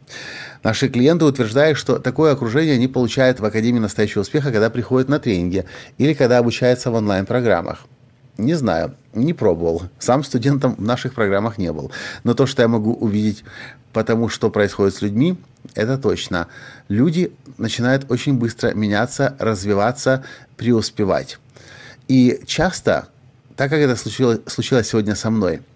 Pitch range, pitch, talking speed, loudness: 110-130 Hz, 120 Hz, 145 wpm, -18 LUFS